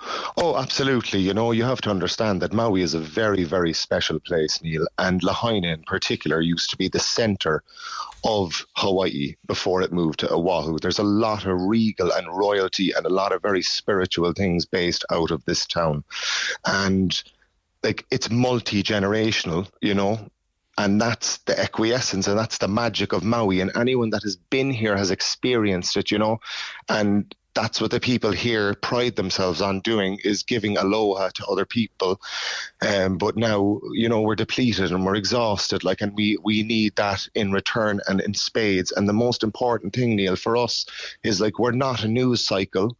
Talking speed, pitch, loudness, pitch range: 185 wpm, 105 Hz, -23 LUFS, 95-115 Hz